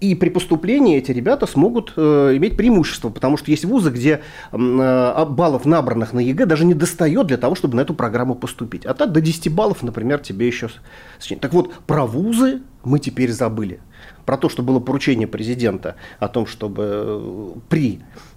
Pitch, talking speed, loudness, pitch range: 140 Hz, 180 wpm, -18 LUFS, 120-165 Hz